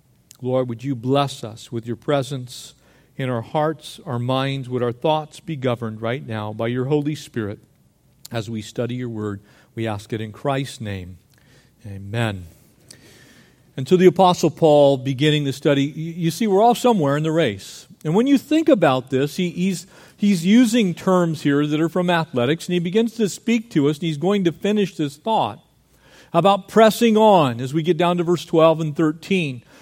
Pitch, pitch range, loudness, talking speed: 150 Hz, 125-175 Hz, -20 LUFS, 190 wpm